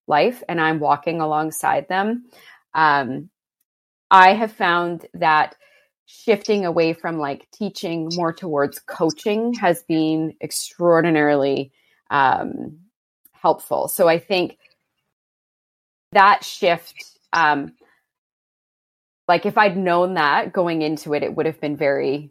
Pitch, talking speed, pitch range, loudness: 165 Hz, 115 wpm, 155-190 Hz, -19 LUFS